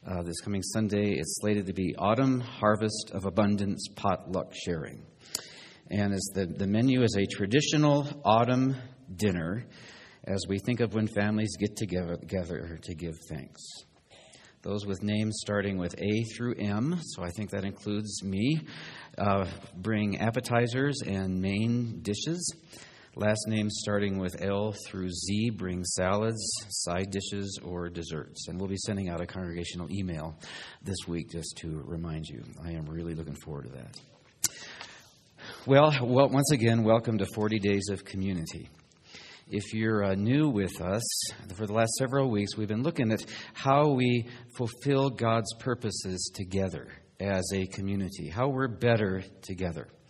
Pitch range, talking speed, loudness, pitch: 95-115 Hz, 155 wpm, -30 LUFS, 105 Hz